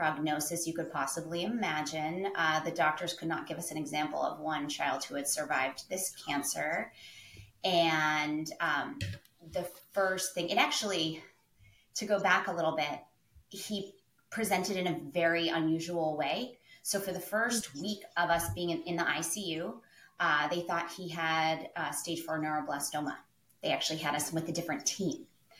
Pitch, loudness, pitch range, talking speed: 165 Hz, -33 LUFS, 155-180 Hz, 165 wpm